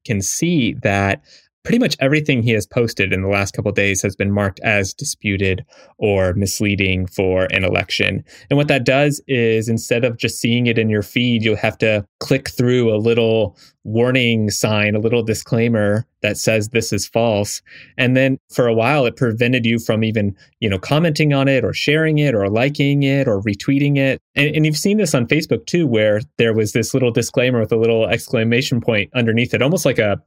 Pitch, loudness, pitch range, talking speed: 115 Hz, -17 LUFS, 105-135 Hz, 205 wpm